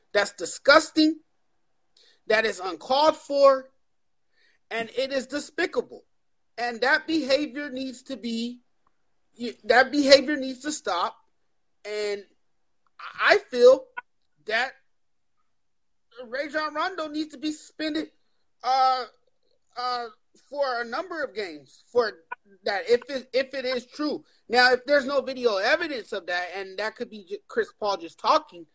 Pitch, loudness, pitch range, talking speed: 270 Hz, -25 LUFS, 240-310 Hz, 130 wpm